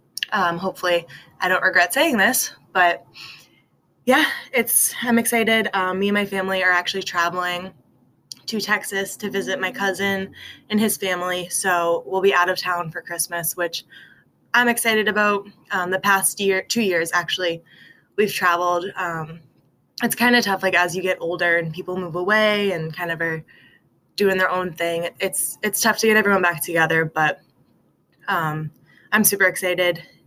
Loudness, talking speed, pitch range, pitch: -20 LUFS, 170 wpm, 170-200 Hz, 185 Hz